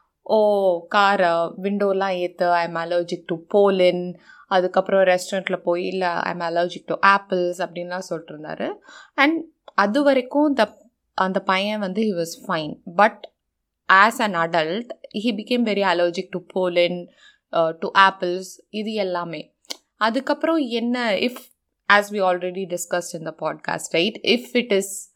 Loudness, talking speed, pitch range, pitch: -21 LUFS, 135 wpm, 175-220 Hz, 195 Hz